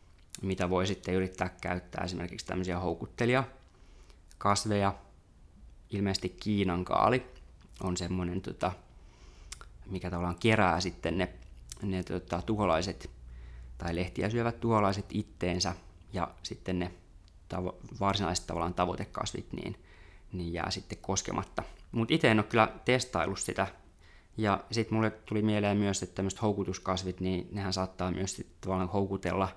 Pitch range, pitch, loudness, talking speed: 90-100 Hz, 95 Hz, -32 LUFS, 125 wpm